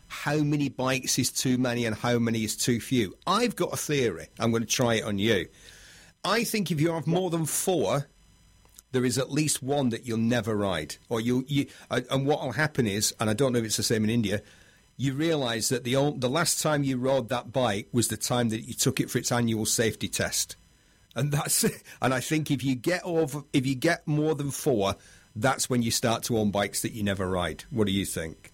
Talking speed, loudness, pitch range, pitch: 240 wpm, -27 LUFS, 110-145 Hz, 125 Hz